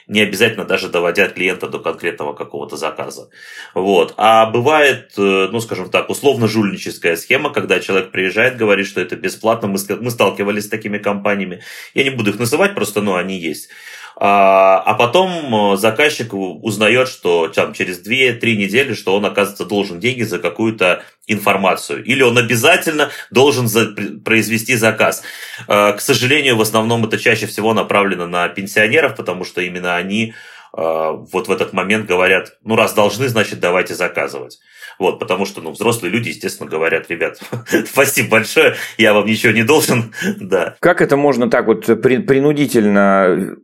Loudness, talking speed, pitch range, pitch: -15 LUFS, 150 wpm, 100-115 Hz, 110 Hz